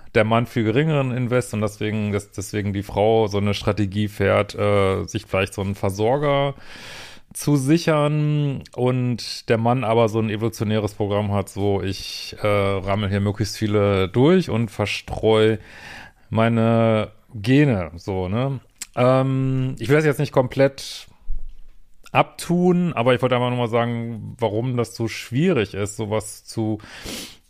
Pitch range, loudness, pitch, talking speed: 105-125 Hz, -21 LUFS, 110 Hz, 150 wpm